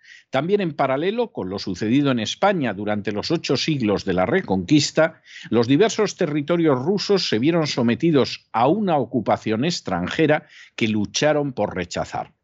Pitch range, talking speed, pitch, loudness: 105-170 Hz, 145 wpm, 145 Hz, -21 LUFS